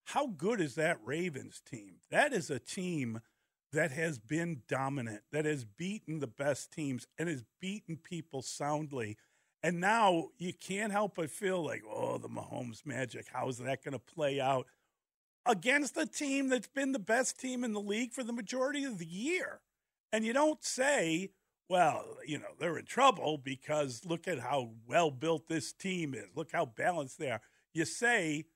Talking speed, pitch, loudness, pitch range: 185 wpm, 165 Hz, -35 LUFS, 140-215 Hz